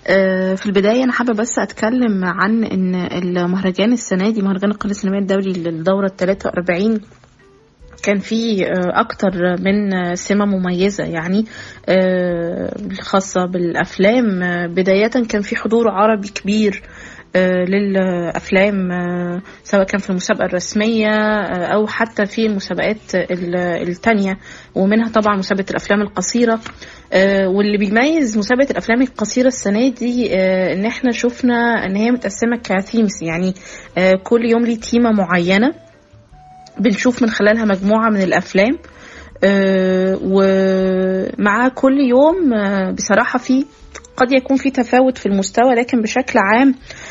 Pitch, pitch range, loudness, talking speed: 200 Hz, 185-230 Hz, -16 LUFS, 125 wpm